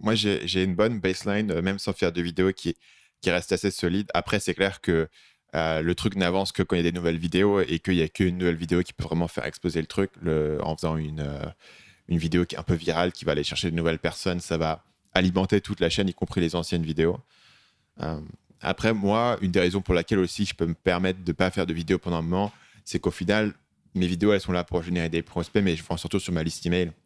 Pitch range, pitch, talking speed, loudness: 85-95 Hz, 90 Hz, 260 wpm, -26 LUFS